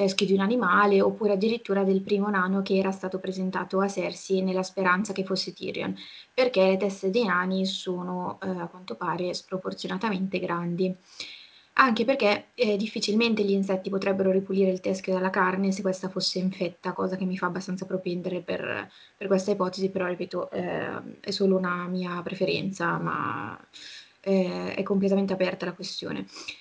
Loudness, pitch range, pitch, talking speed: -27 LUFS, 185-195 Hz, 190 Hz, 165 wpm